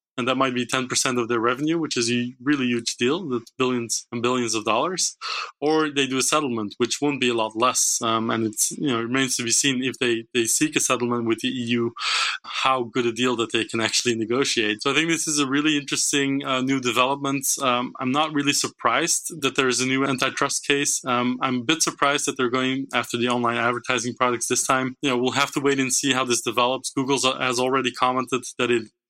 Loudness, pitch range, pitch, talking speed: -22 LUFS, 120-140 Hz, 130 Hz, 235 wpm